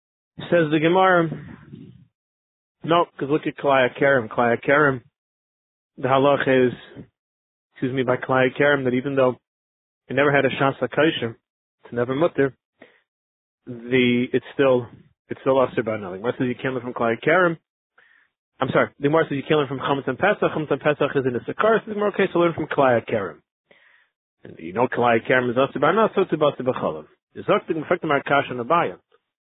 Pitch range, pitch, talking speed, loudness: 125-155 Hz, 135 Hz, 180 wpm, -21 LUFS